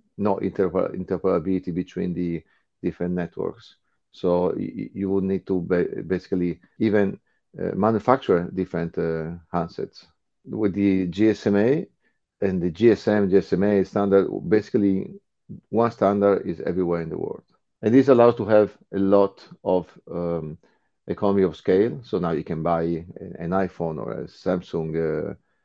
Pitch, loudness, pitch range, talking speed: 95 Hz, -23 LUFS, 85-100 Hz, 140 wpm